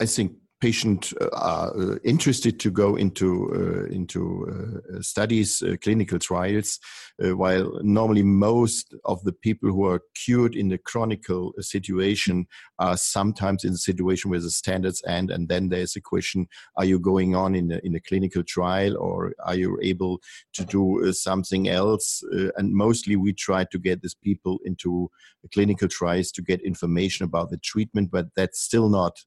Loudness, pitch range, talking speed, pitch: -24 LUFS, 90-105 Hz, 180 wpm, 95 Hz